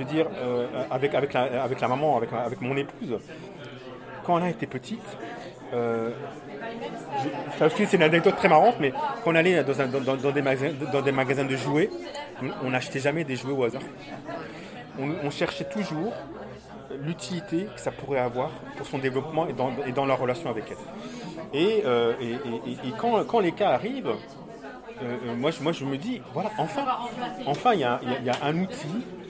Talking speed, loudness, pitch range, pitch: 190 wpm, -27 LUFS, 130-175 Hz, 140 Hz